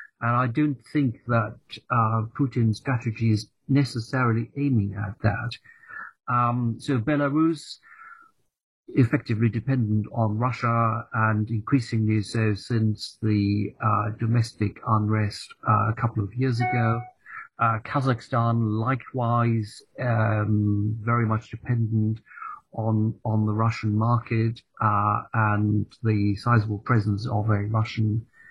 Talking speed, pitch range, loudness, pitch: 115 wpm, 110-125 Hz, -25 LUFS, 115 Hz